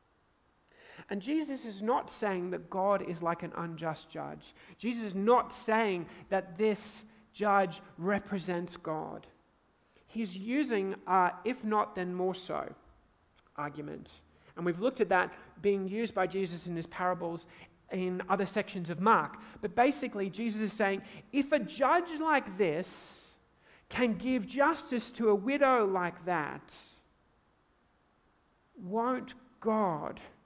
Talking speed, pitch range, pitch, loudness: 130 wpm, 175-225 Hz, 195 Hz, -32 LUFS